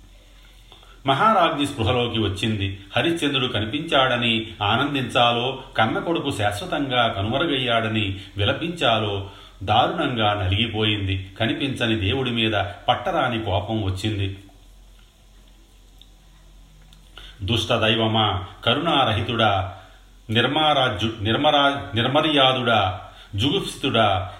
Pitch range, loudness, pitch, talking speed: 100-125 Hz, -21 LUFS, 110 Hz, 60 wpm